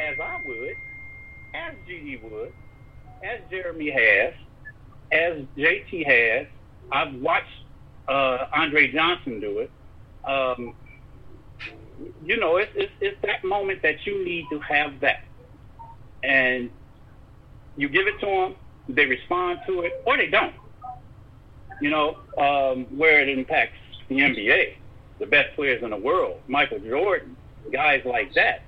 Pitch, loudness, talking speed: 150 Hz, -22 LUFS, 135 wpm